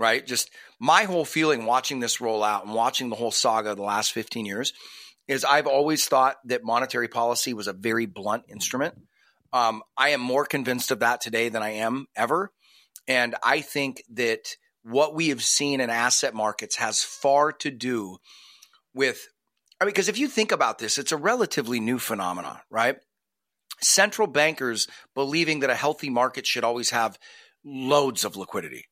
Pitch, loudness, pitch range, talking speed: 130 Hz, -24 LUFS, 115-150 Hz, 180 wpm